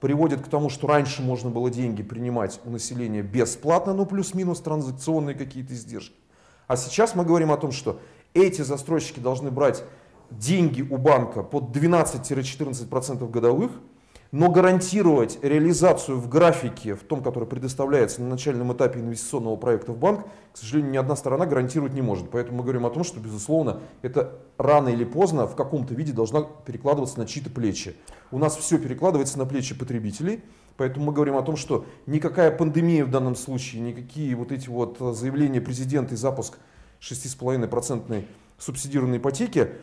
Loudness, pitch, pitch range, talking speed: -24 LUFS, 135 Hz, 120-155 Hz, 160 wpm